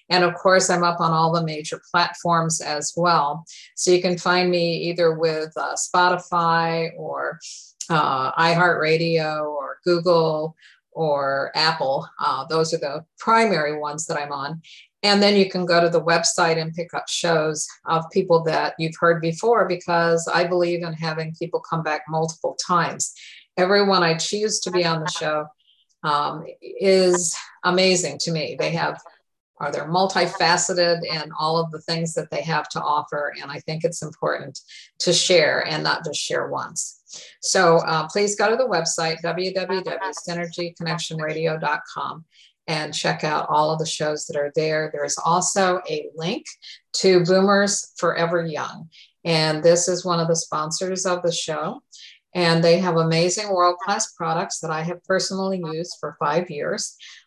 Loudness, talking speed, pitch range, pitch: -21 LUFS, 160 wpm, 160-180 Hz, 170 Hz